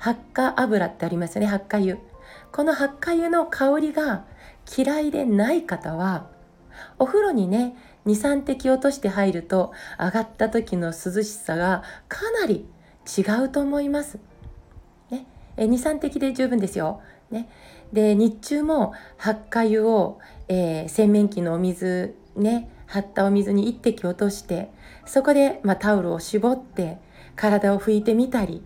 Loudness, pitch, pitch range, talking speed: -23 LUFS, 215 Hz, 195-265 Hz, 260 characters per minute